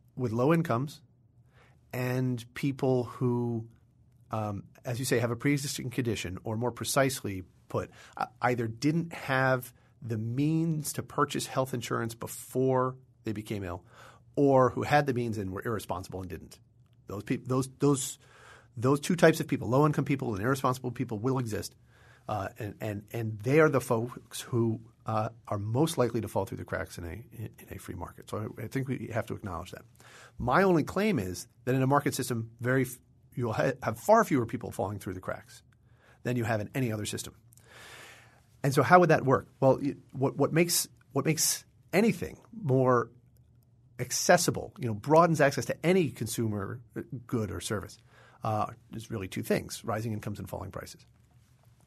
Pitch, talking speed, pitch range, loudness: 120 Hz, 180 wpm, 115-130 Hz, -30 LUFS